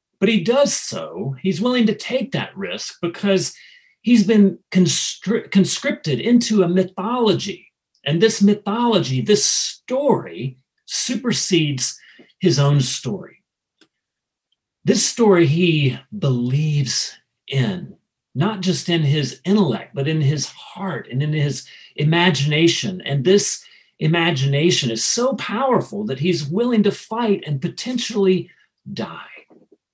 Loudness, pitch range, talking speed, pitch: -19 LUFS, 150-215 Hz, 120 wpm, 185 Hz